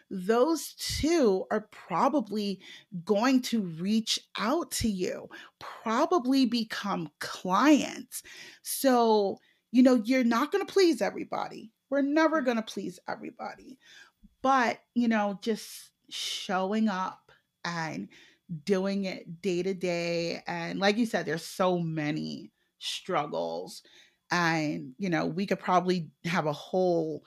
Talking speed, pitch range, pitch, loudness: 125 wpm, 180-255 Hz, 210 Hz, -29 LUFS